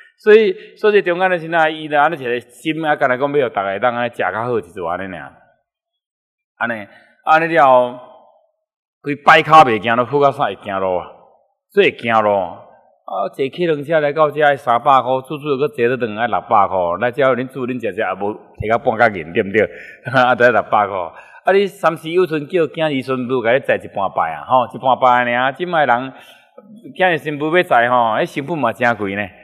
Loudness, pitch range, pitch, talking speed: -16 LUFS, 125-170 Hz, 145 Hz, 285 characters per minute